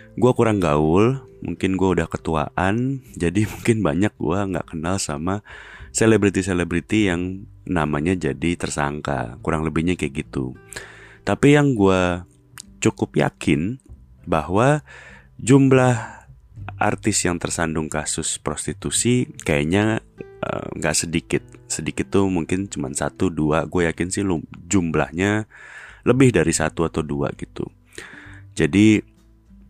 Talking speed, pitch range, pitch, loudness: 115 wpm, 80-105 Hz, 95 Hz, -21 LUFS